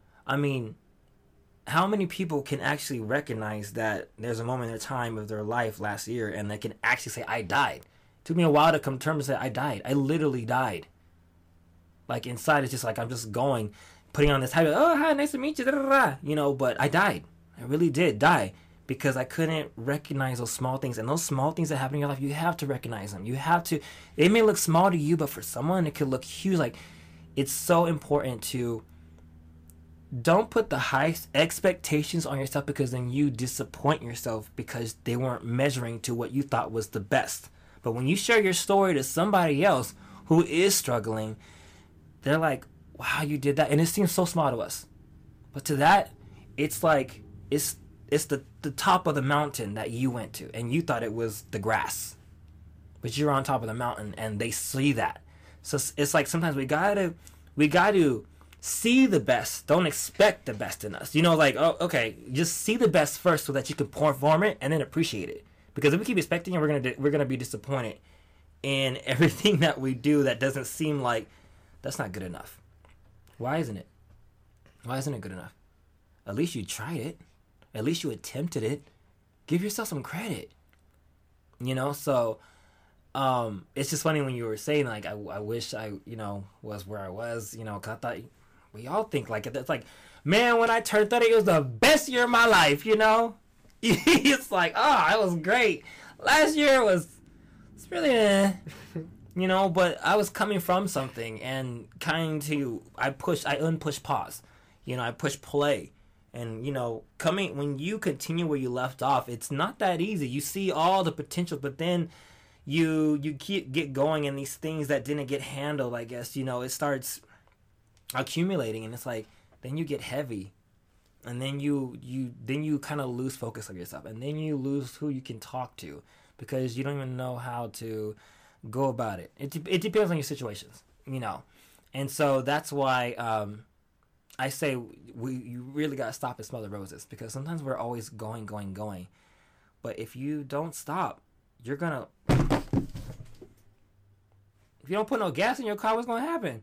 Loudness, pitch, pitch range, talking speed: -27 LUFS, 135 Hz, 110-155 Hz, 200 wpm